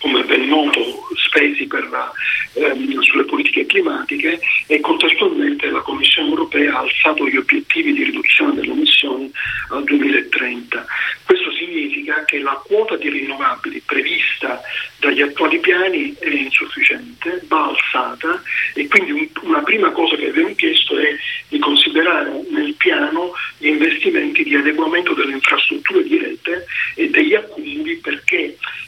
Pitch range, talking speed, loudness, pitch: 310-370 Hz, 135 wpm, -15 LUFS, 335 Hz